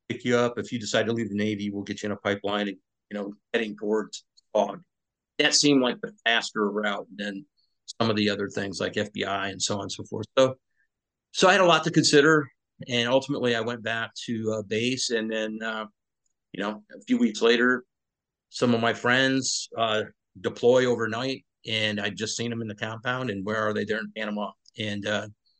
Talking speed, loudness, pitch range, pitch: 215 wpm, -26 LUFS, 105-125 Hz, 110 Hz